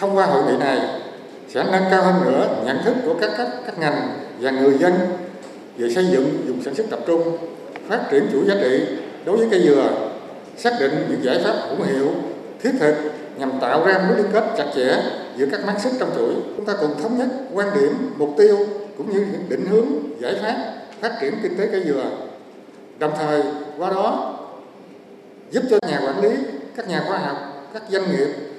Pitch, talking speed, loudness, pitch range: 190 Hz, 210 wpm, -20 LUFS, 150-215 Hz